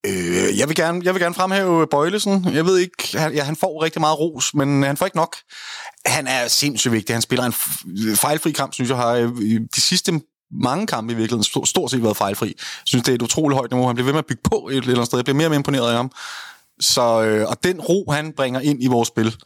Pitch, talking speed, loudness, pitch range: 140 Hz, 250 wpm, -19 LUFS, 120-160 Hz